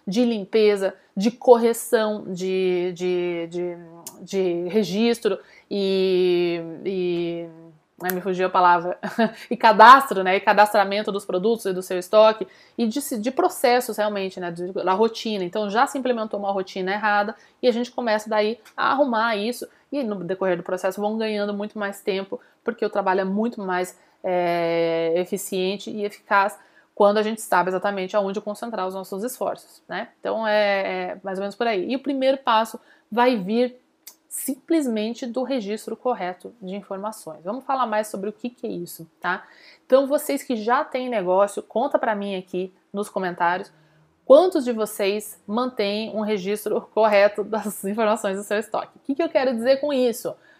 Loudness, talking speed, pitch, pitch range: -22 LUFS, 165 wpm, 210 Hz, 190-235 Hz